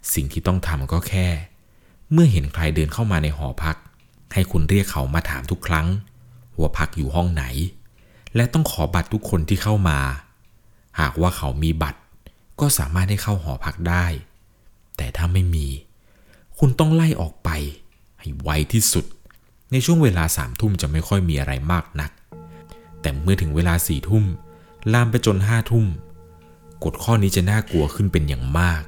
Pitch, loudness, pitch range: 85 Hz, -21 LUFS, 80-105 Hz